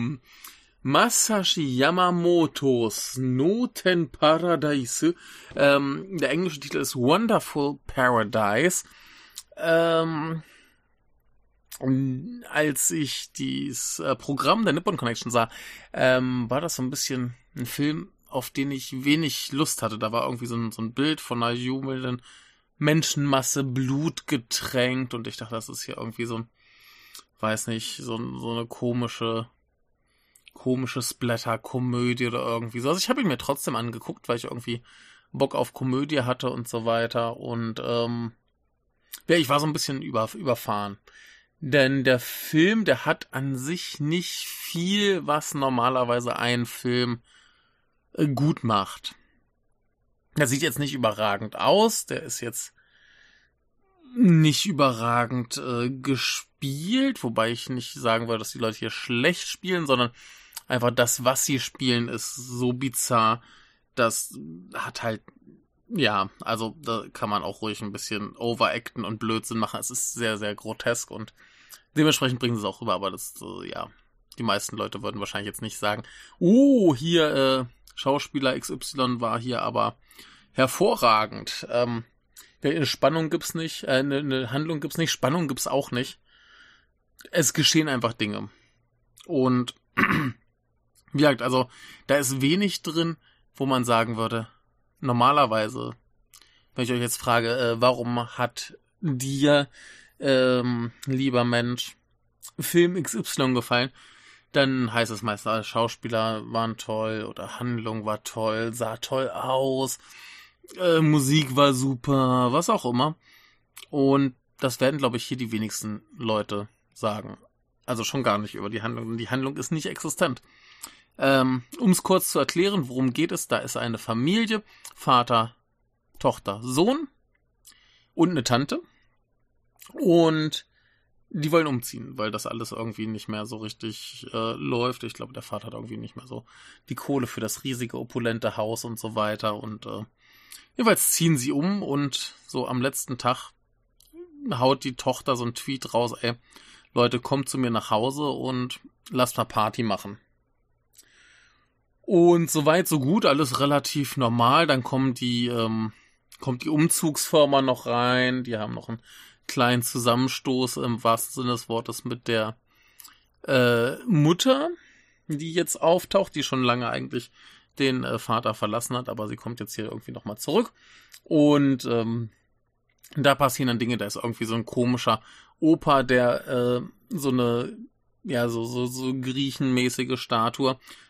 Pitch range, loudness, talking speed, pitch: 115-145 Hz, -25 LUFS, 145 wpm, 125 Hz